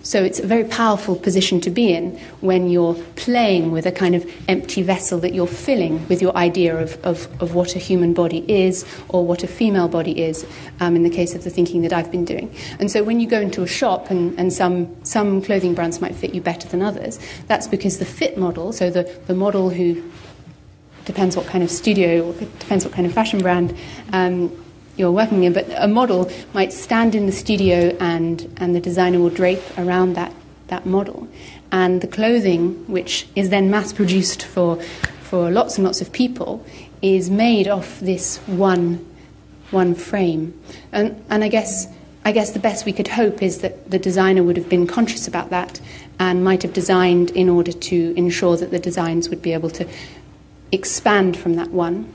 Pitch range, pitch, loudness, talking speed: 175-195 Hz, 180 Hz, -19 LUFS, 200 wpm